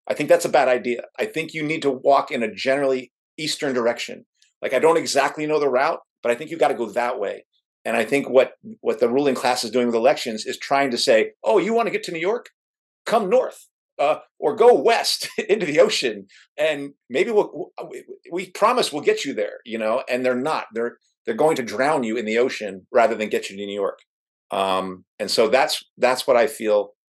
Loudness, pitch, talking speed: -21 LUFS, 140 Hz, 230 wpm